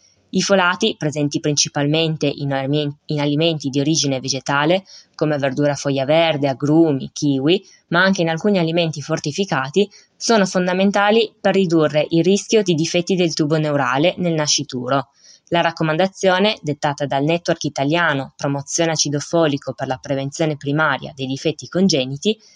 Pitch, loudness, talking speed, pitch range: 155 Hz, -18 LUFS, 130 wpm, 145-175 Hz